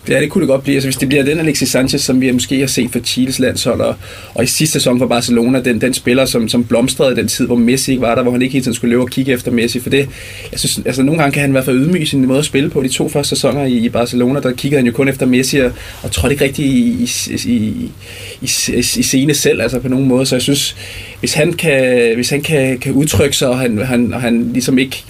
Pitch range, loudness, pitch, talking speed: 125-140 Hz, -13 LUFS, 130 Hz, 285 wpm